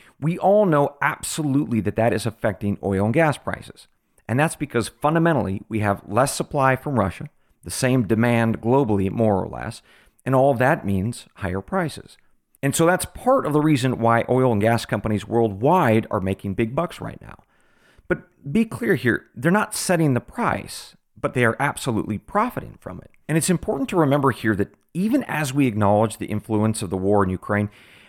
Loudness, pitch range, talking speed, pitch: -21 LUFS, 105-150 Hz, 190 wpm, 120 Hz